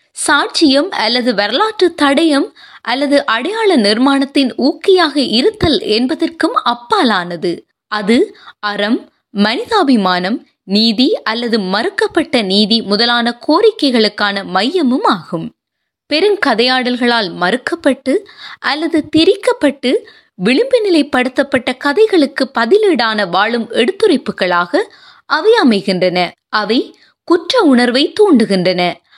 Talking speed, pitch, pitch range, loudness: 80 wpm, 270 Hz, 220-340 Hz, -13 LUFS